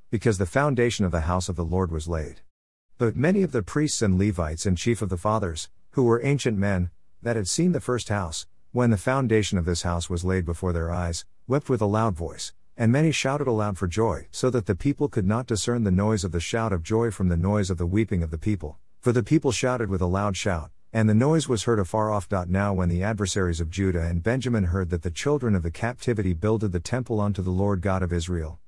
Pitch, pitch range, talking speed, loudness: 105 Hz, 90-115 Hz, 245 wpm, -25 LUFS